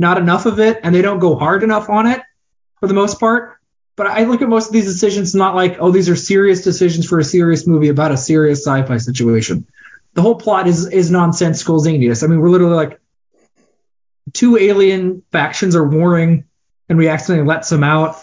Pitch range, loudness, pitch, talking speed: 160-195 Hz, -13 LUFS, 175 Hz, 205 wpm